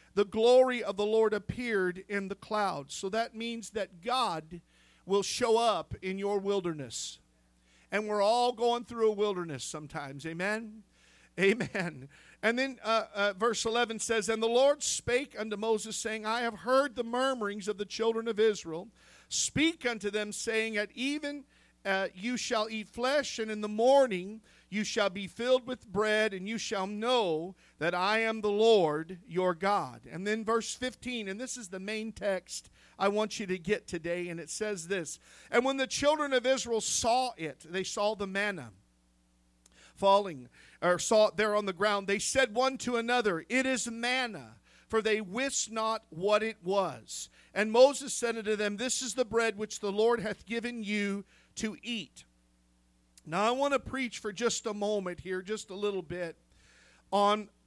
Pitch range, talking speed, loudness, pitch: 190-235 Hz, 180 wpm, -31 LUFS, 210 Hz